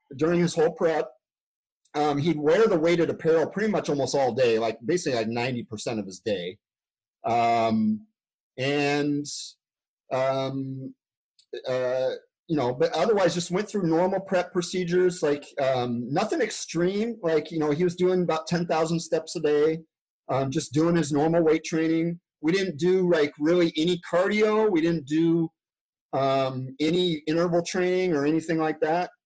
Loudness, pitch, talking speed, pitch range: -25 LUFS, 160 Hz, 160 wpm, 145-180 Hz